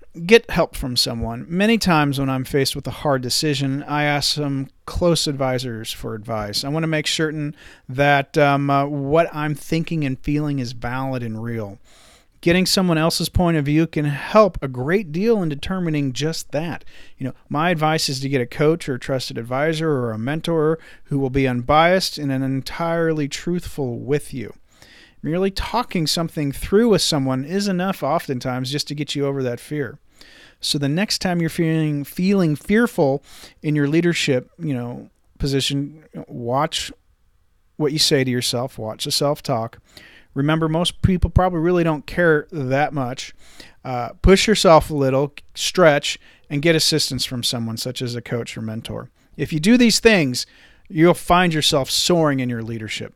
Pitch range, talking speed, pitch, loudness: 130-165 Hz, 175 wpm, 145 Hz, -20 LUFS